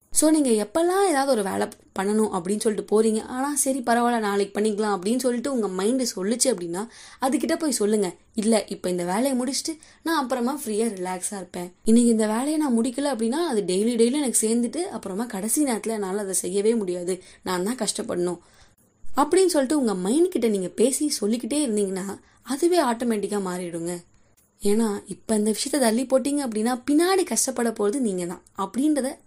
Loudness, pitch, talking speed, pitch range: -24 LUFS, 225 Hz, 160 wpm, 200-265 Hz